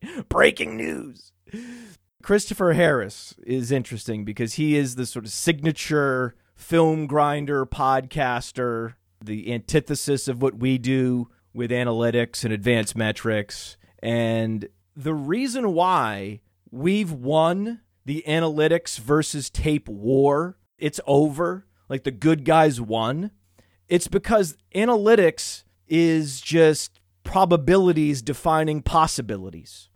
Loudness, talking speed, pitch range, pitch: -22 LUFS, 105 wpm, 115-160 Hz, 135 Hz